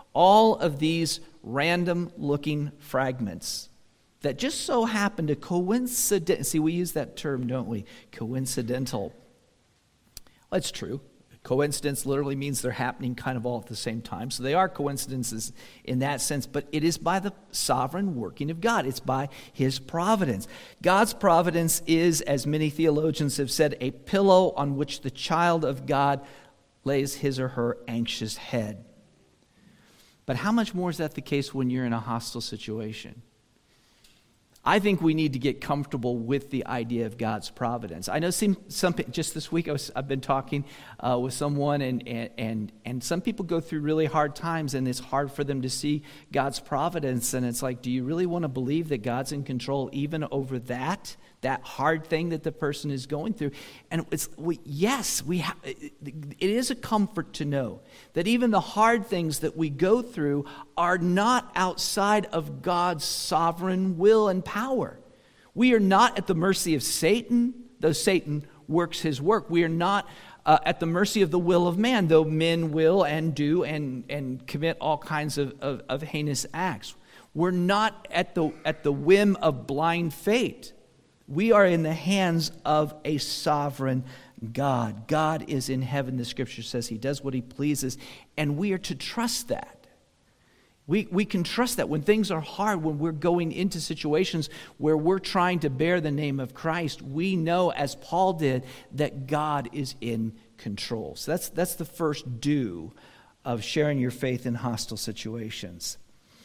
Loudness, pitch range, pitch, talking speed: -27 LUFS, 130-175 Hz, 150 Hz, 180 wpm